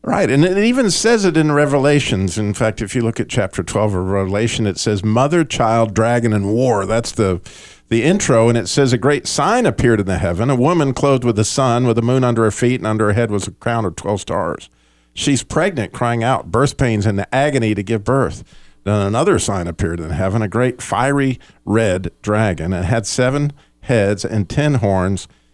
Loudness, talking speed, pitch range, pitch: -16 LUFS, 215 wpm, 100-130 Hz, 115 Hz